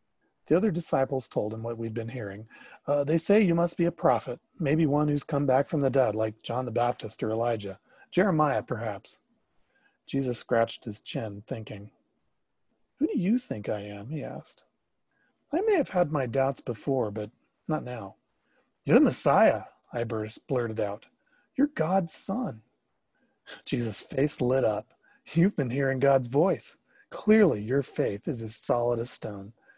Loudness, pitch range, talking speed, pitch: -28 LUFS, 115-160 Hz, 165 wpm, 135 Hz